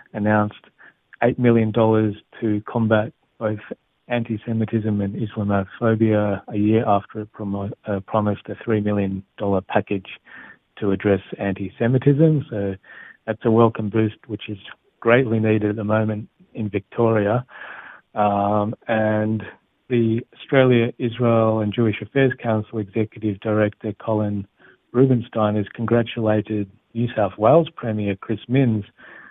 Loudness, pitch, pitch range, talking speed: -21 LUFS, 110 Hz, 105-115 Hz, 125 wpm